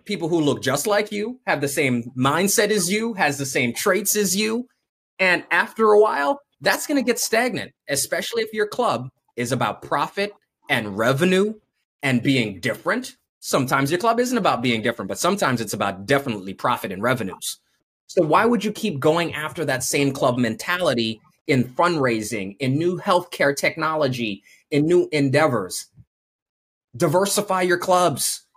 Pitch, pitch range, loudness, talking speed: 155 Hz, 130-205 Hz, -21 LUFS, 160 wpm